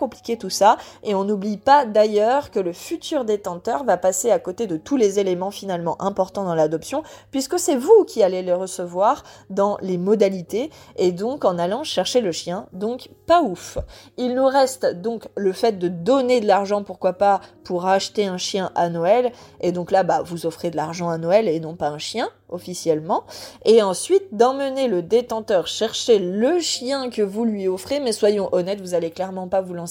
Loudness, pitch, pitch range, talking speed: -21 LUFS, 200 Hz, 180-245 Hz, 200 wpm